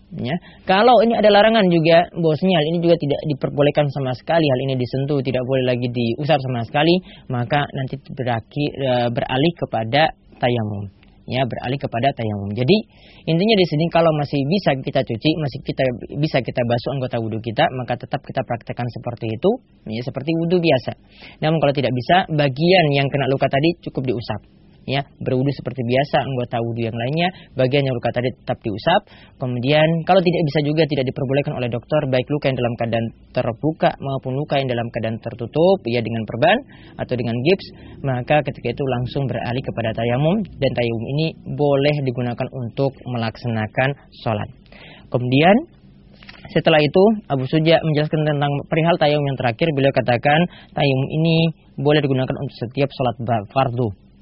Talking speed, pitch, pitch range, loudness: 165 wpm, 135 Hz, 125-155 Hz, -19 LUFS